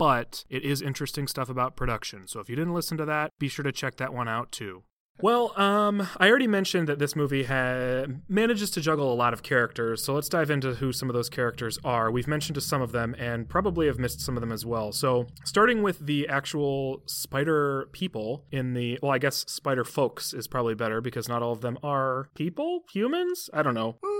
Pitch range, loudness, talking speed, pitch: 125-155 Hz, -27 LUFS, 225 wpm, 140 Hz